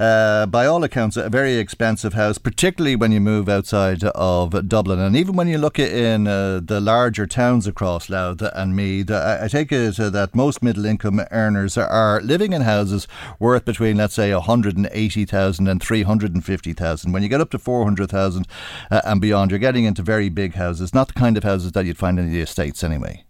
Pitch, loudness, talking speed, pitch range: 105 Hz, -19 LUFS, 190 wpm, 95-115 Hz